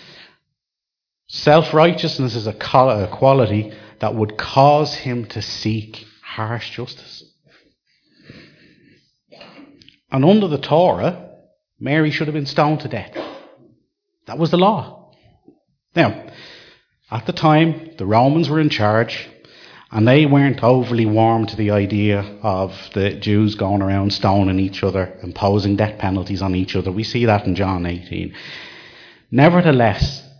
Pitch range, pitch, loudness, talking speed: 100-140 Hz, 110 Hz, -17 LUFS, 130 wpm